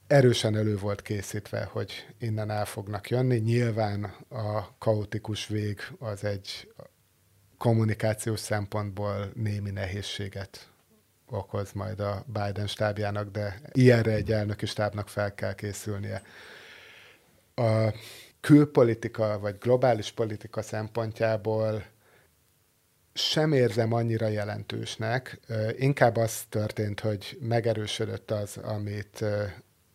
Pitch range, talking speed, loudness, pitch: 105-115 Hz, 100 wpm, -28 LUFS, 110 Hz